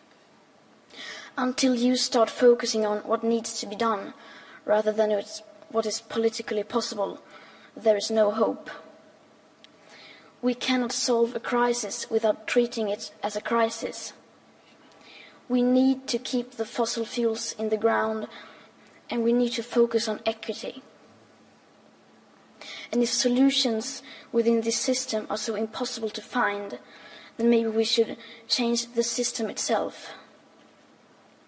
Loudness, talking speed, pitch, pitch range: -25 LUFS, 130 wpm, 230 Hz, 220-245 Hz